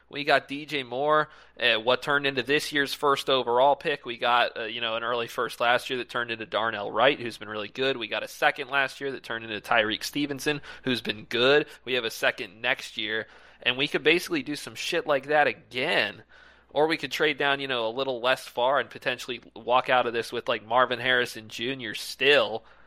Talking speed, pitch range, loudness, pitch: 225 wpm, 120-140 Hz, -26 LUFS, 130 Hz